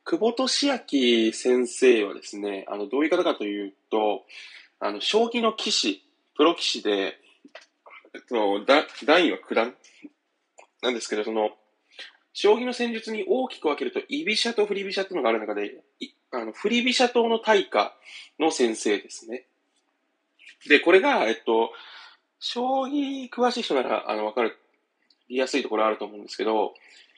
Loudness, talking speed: -24 LUFS, 300 characters per minute